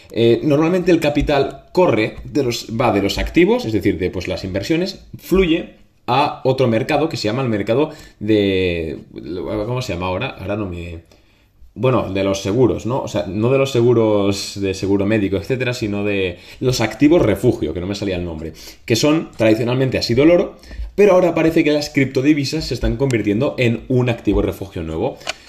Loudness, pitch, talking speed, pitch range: -18 LUFS, 110 Hz, 190 wpm, 100-140 Hz